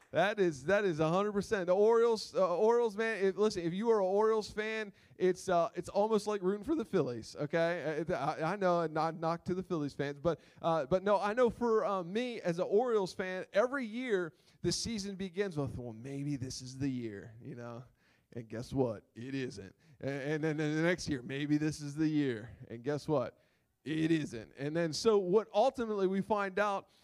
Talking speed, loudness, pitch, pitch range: 205 wpm, -33 LUFS, 175 Hz, 145-205 Hz